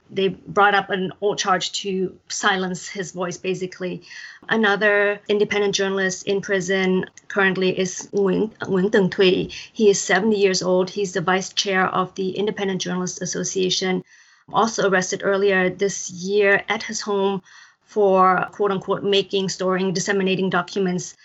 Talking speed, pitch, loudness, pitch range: 140 wpm, 195 Hz, -21 LUFS, 185-200 Hz